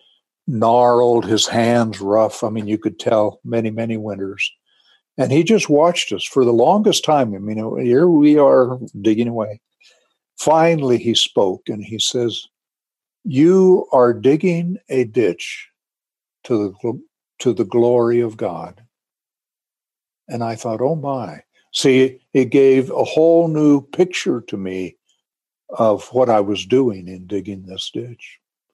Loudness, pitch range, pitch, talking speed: -17 LUFS, 110-135 Hz, 120 Hz, 145 wpm